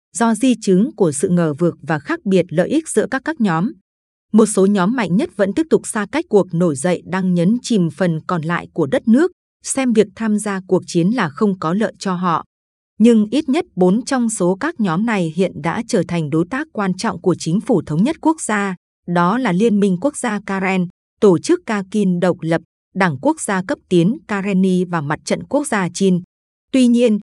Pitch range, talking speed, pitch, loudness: 180-230 Hz, 220 wpm, 200 Hz, -17 LUFS